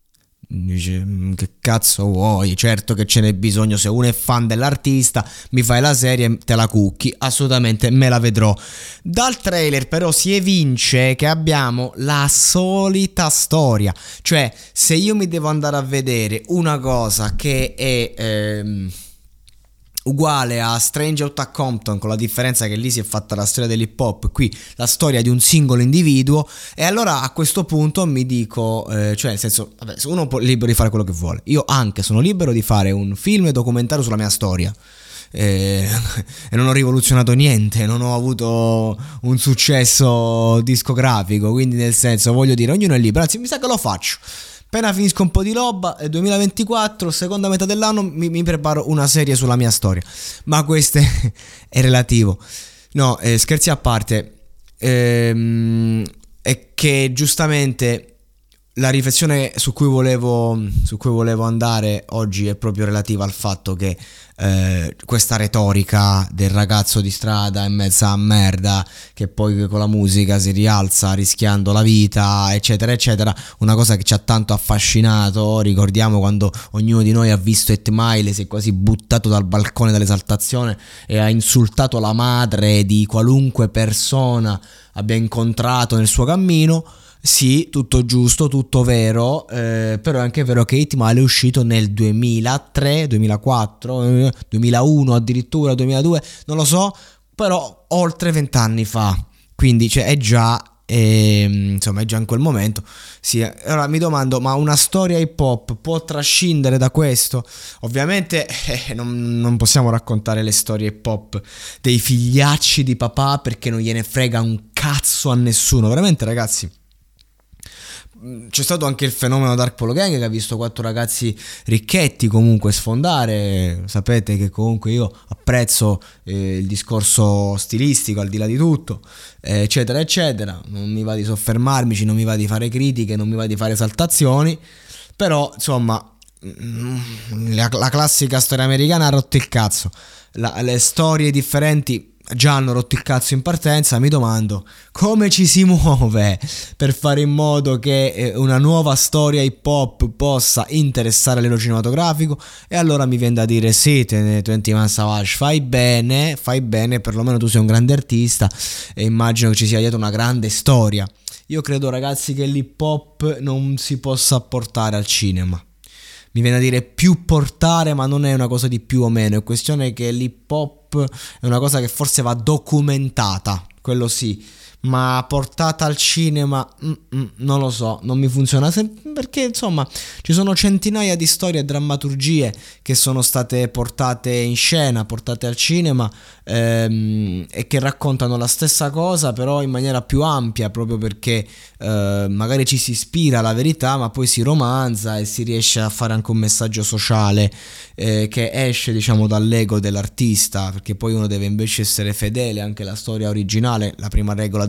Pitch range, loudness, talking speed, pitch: 110-140 Hz, -16 LUFS, 160 wpm, 120 Hz